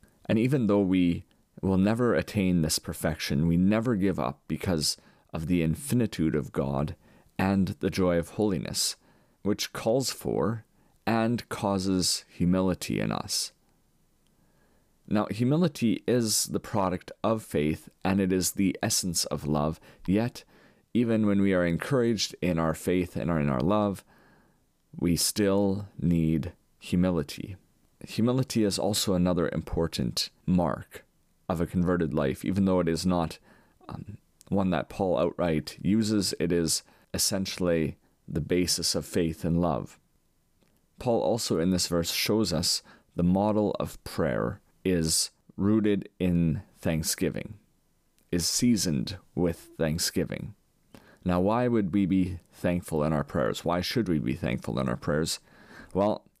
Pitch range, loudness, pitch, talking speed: 85-100 Hz, -28 LUFS, 90 Hz, 140 wpm